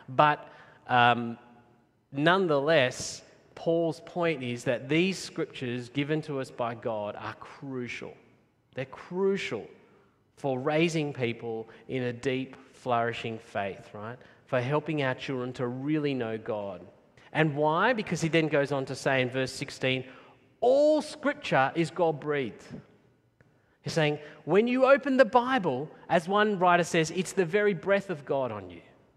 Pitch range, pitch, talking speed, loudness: 125-170 Hz, 145 Hz, 145 wpm, -28 LUFS